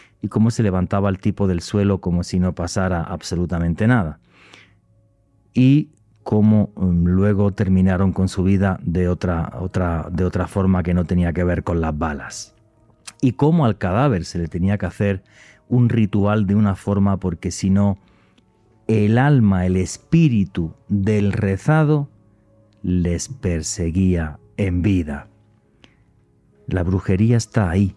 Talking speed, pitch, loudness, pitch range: 140 wpm, 100 Hz, -19 LUFS, 90-110 Hz